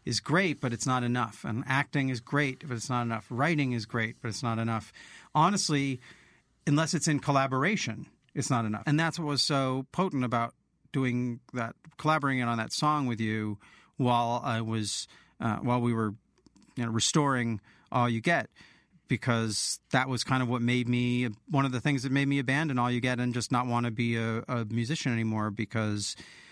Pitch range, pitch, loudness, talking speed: 115-140 Hz, 125 Hz, -29 LUFS, 195 wpm